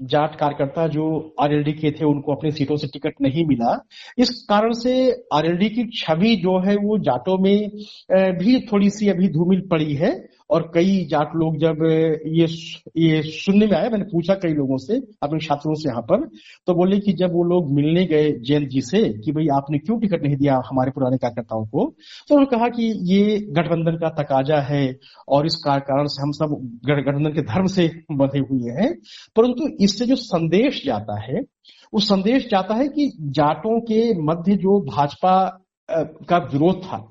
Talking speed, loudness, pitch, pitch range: 185 wpm, -20 LUFS, 165 Hz, 145-205 Hz